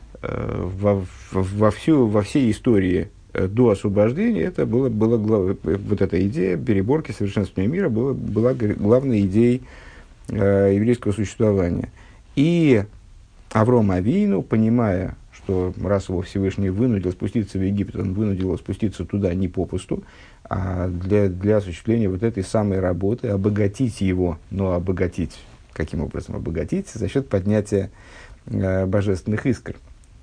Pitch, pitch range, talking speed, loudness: 100 Hz, 95-115 Hz, 125 wpm, -21 LUFS